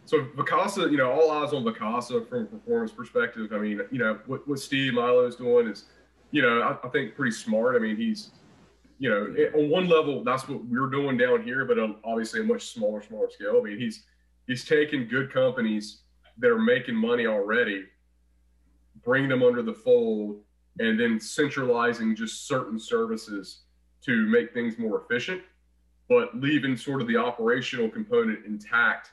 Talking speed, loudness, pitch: 180 wpm, -26 LUFS, 155 Hz